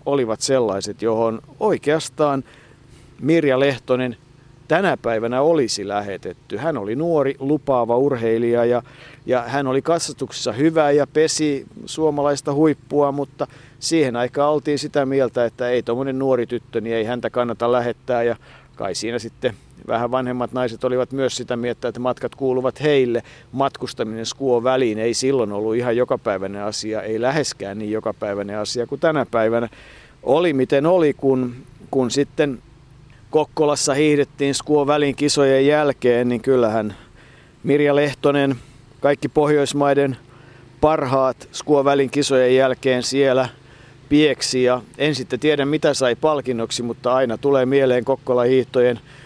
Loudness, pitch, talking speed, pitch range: -20 LUFS, 130 Hz, 130 wpm, 120-145 Hz